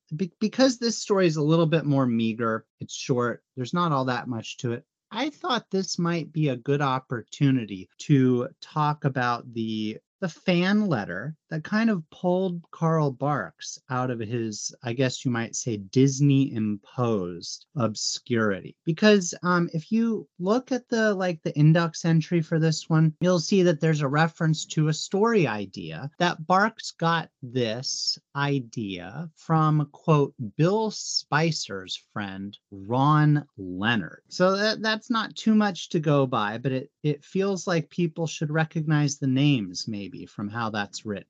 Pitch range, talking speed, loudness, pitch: 125-175 Hz, 160 wpm, -25 LUFS, 155 Hz